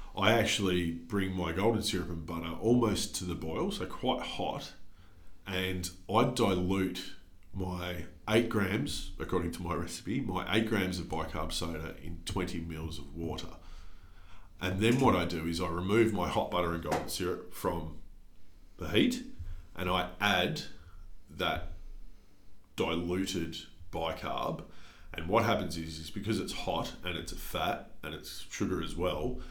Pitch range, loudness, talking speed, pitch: 85-95 Hz, -33 LUFS, 155 wpm, 90 Hz